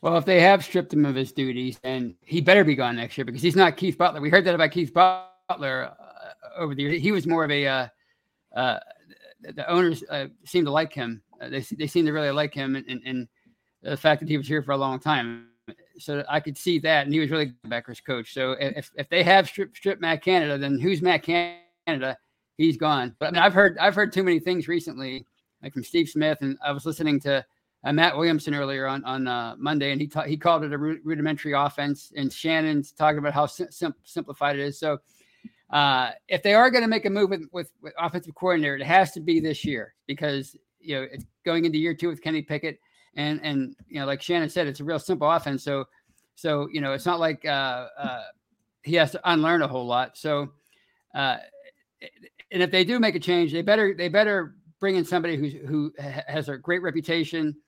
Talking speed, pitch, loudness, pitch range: 230 wpm, 155 Hz, -24 LUFS, 140-175 Hz